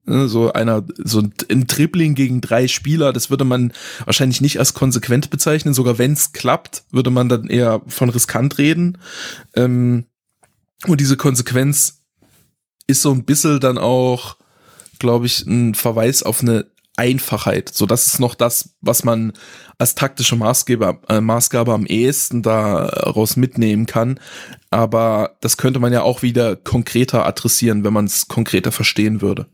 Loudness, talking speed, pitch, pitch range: -16 LUFS, 150 wpm, 120 Hz, 115-135 Hz